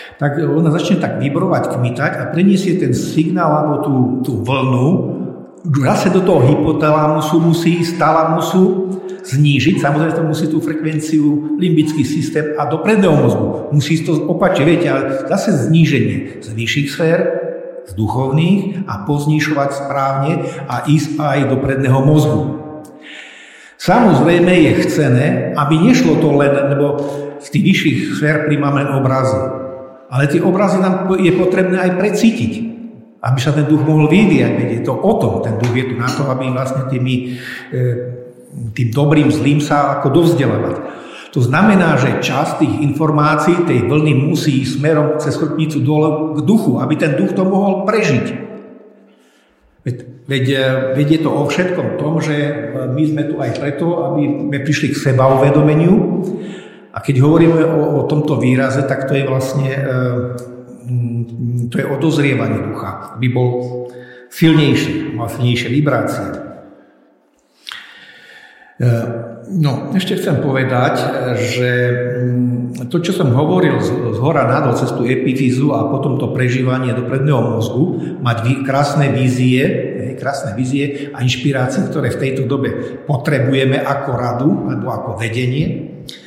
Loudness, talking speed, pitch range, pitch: -15 LUFS, 140 wpm, 130-160 Hz, 145 Hz